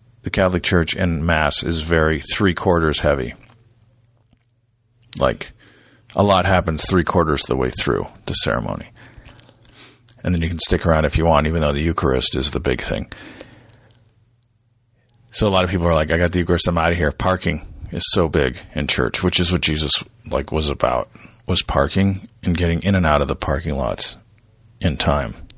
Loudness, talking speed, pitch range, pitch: -18 LUFS, 190 wpm, 80-110 Hz, 90 Hz